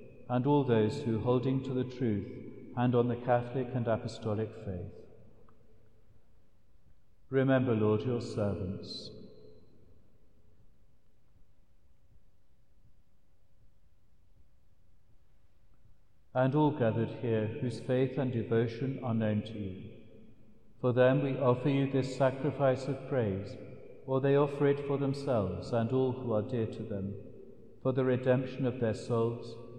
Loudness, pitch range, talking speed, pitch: -32 LUFS, 105-130 Hz, 120 wpm, 115 Hz